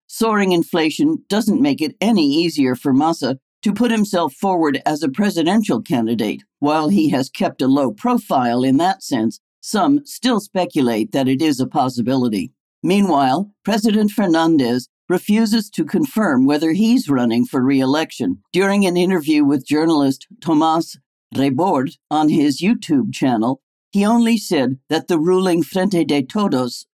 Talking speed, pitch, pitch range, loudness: 145 wpm, 175 Hz, 140-215 Hz, -17 LUFS